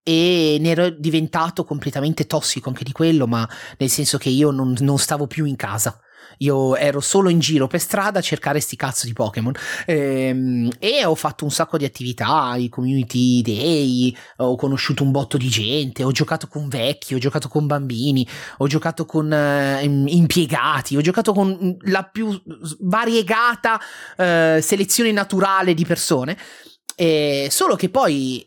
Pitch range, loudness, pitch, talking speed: 135-165 Hz, -19 LUFS, 150 Hz, 165 wpm